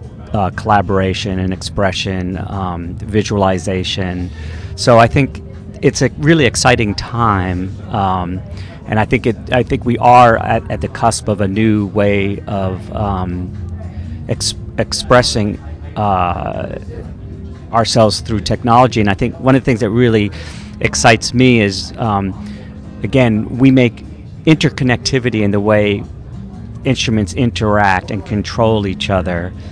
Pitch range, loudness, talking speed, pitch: 95-115 Hz, -14 LUFS, 130 wpm, 105 Hz